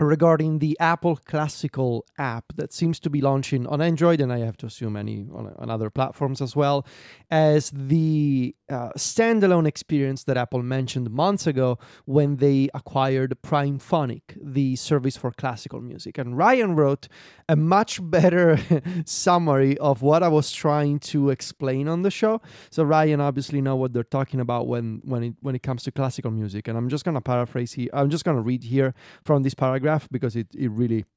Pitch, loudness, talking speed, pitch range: 140 Hz, -23 LUFS, 185 wpm, 125-155 Hz